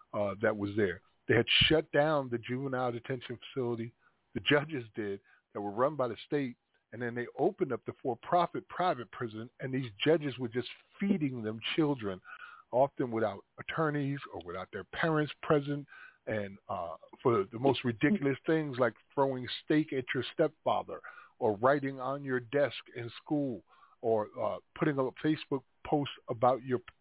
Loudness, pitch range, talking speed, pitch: -33 LUFS, 120-145 Hz, 165 wpm, 130 Hz